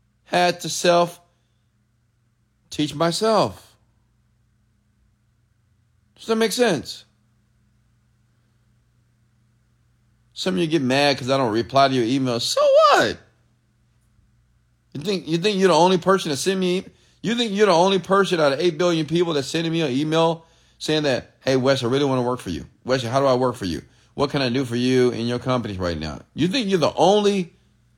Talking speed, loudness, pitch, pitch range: 180 wpm, -20 LUFS, 125 Hz, 115-170 Hz